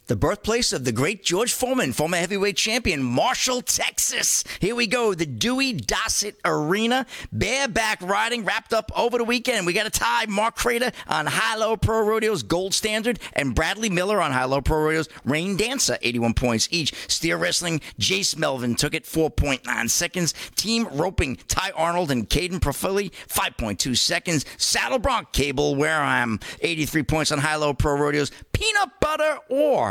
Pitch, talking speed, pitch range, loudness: 190 Hz, 170 wpm, 150-230 Hz, -22 LUFS